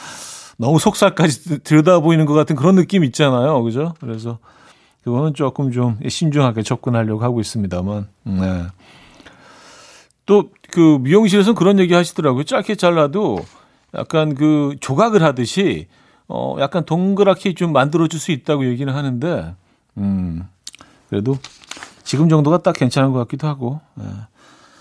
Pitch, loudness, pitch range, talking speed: 145 Hz, -16 LUFS, 120-170 Hz, 300 characters per minute